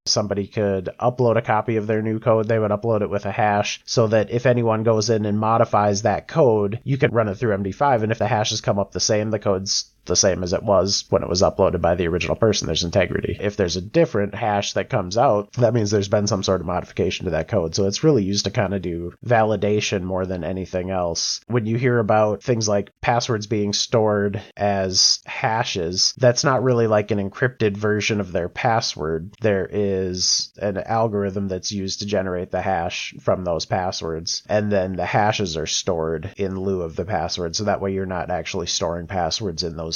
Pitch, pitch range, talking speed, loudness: 105 Hz, 95-115 Hz, 220 wpm, -21 LUFS